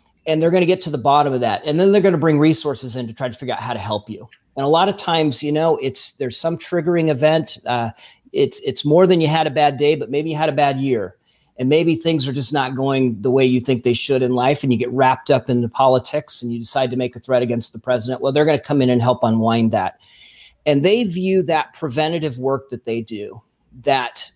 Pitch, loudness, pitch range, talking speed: 135 Hz, -18 LUFS, 125-155 Hz, 270 wpm